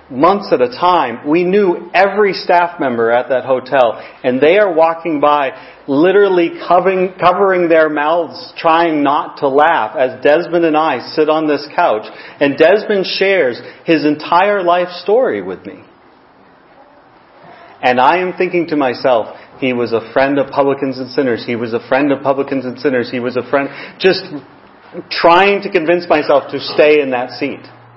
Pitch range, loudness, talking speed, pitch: 135-180 Hz, -13 LUFS, 170 wpm, 155 Hz